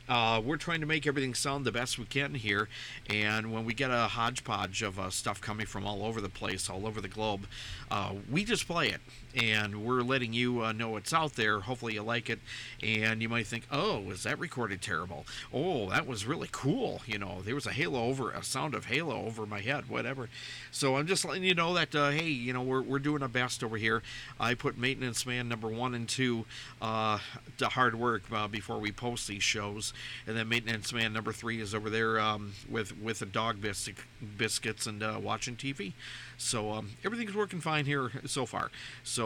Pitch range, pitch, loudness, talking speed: 110-130 Hz, 115 Hz, -33 LUFS, 215 wpm